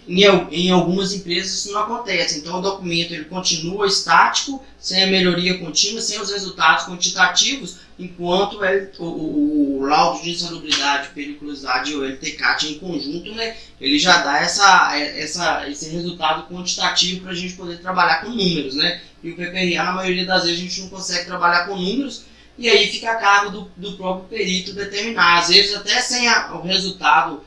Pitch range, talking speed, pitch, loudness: 170-200 Hz, 180 wpm, 180 Hz, -18 LUFS